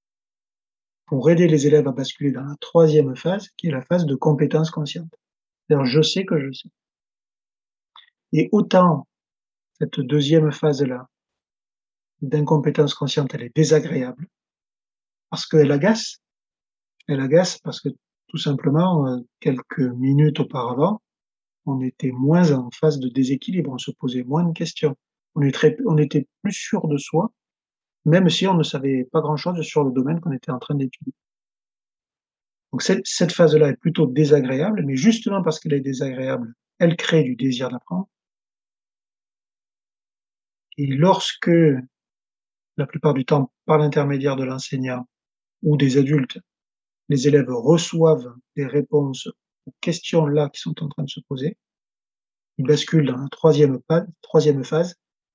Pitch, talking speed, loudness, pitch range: 150 Hz, 140 wpm, -20 LUFS, 135-165 Hz